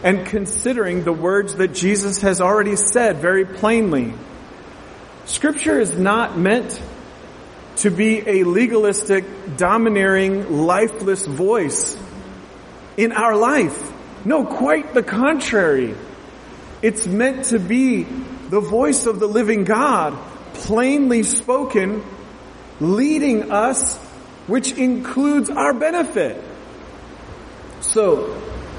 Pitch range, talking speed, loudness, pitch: 195-250 Hz, 100 wpm, -18 LUFS, 215 Hz